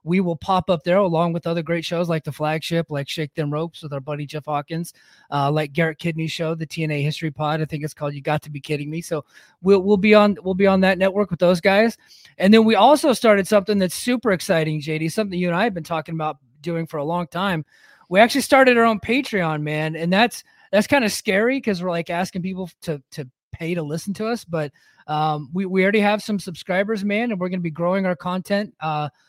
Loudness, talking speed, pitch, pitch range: -20 LUFS, 245 wpm, 175 Hz, 155-200 Hz